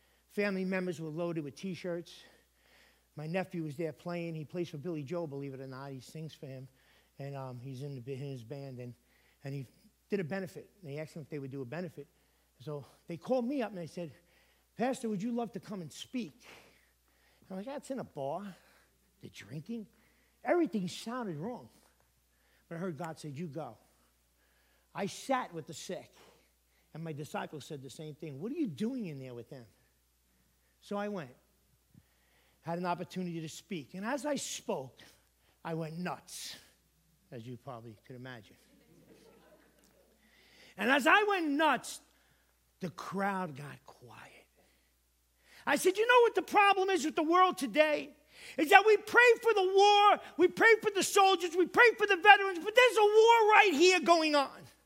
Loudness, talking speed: -30 LUFS, 185 wpm